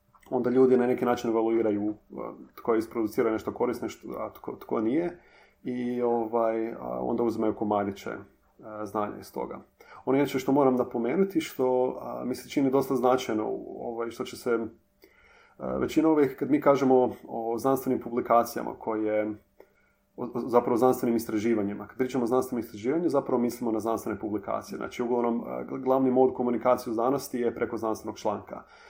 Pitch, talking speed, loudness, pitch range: 120 Hz, 150 wpm, -28 LUFS, 110-130 Hz